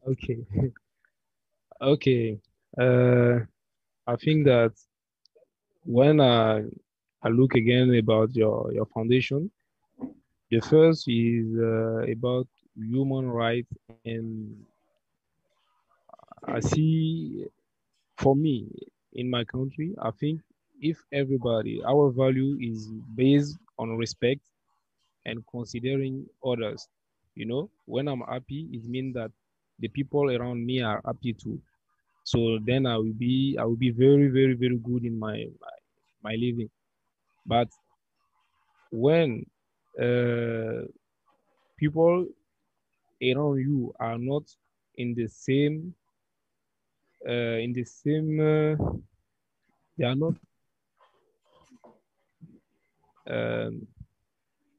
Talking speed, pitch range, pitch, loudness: 105 wpm, 115-140 Hz, 125 Hz, -26 LUFS